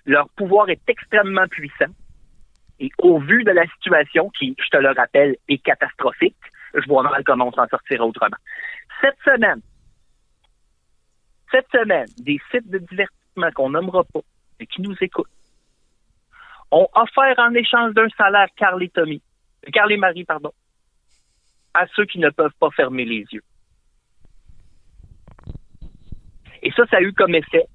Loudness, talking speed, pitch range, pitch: -18 LUFS, 145 wpm, 165-245 Hz, 200 Hz